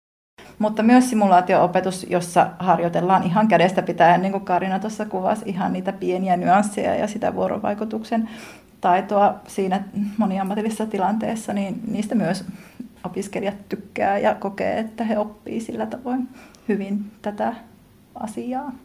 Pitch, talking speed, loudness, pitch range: 200 Hz, 125 wpm, -21 LUFS, 185-220 Hz